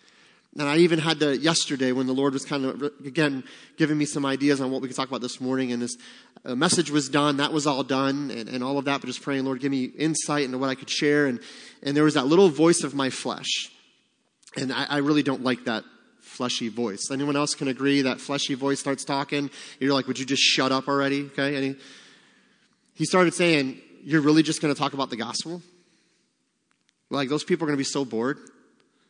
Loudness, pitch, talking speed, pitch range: -24 LUFS, 140 Hz, 230 wpm, 135-150 Hz